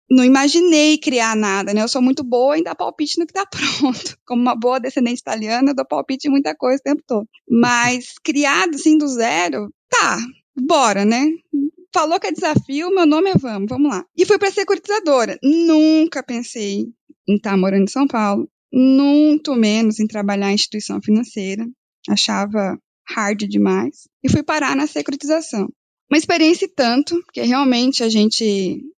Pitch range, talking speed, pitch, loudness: 225-305 Hz, 175 wpm, 265 Hz, -17 LUFS